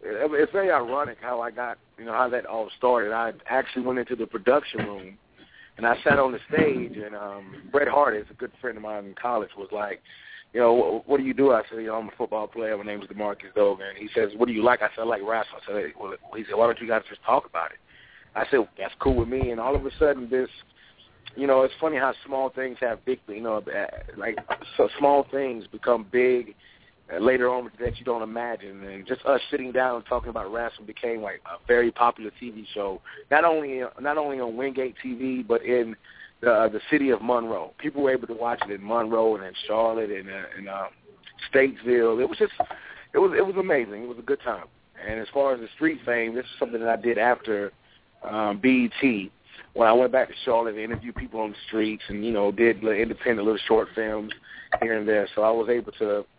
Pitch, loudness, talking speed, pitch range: 115 Hz, -25 LUFS, 240 wpm, 110-130 Hz